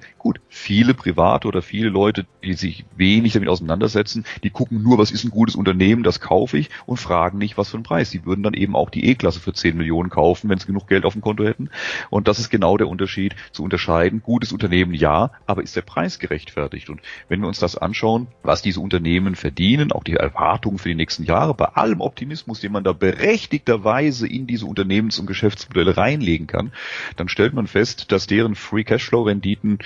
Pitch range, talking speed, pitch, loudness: 90-110 Hz, 210 wpm, 100 Hz, -19 LUFS